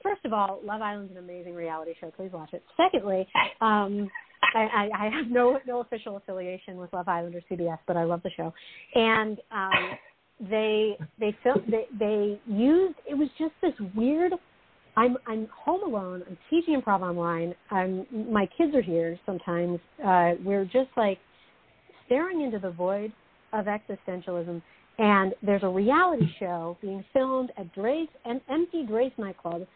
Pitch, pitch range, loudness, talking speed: 205 Hz, 180-245 Hz, -27 LUFS, 165 wpm